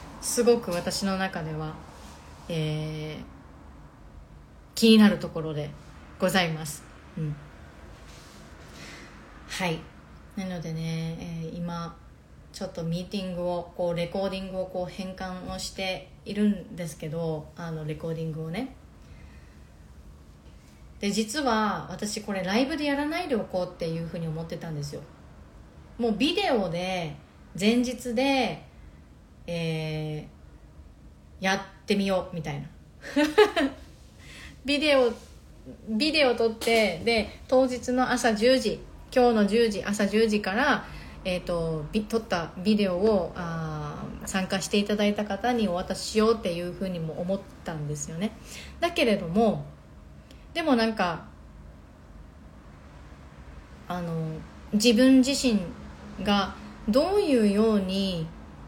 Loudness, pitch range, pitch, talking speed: -27 LUFS, 155-215 Hz, 180 Hz, 230 characters per minute